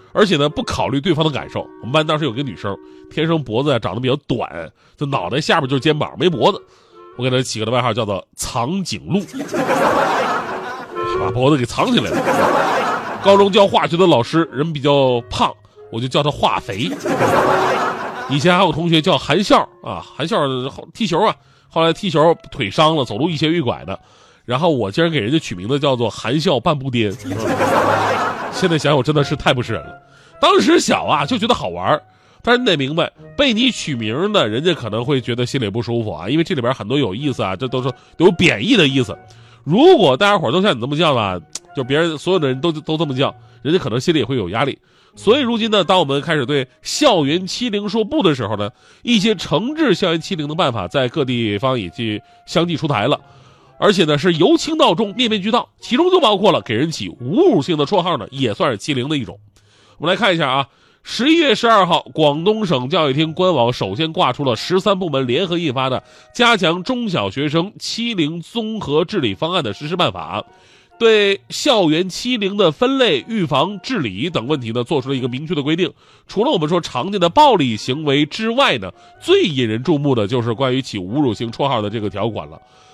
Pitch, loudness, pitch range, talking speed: 150 Hz, -17 LUFS, 125-185 Hz, 305 characters per minute